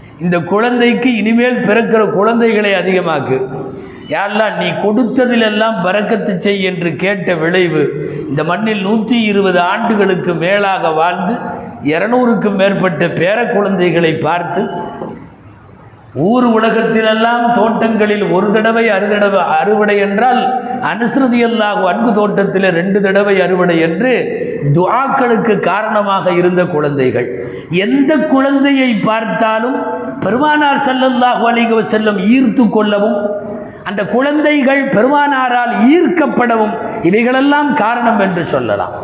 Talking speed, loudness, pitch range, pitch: 95 wpm, -12 LUFS, 185-240 Hz, 215 Hz